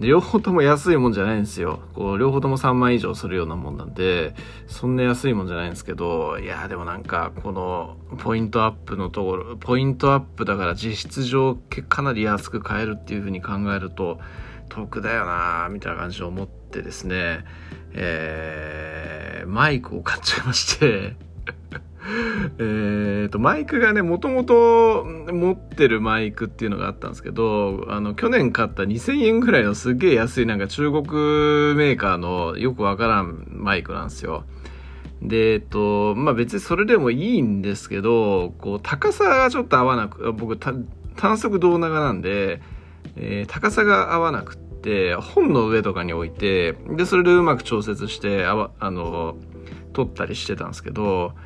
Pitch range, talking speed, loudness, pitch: 90-130 Hz, 340 characters per minute, -21 LUFS, 105 Hz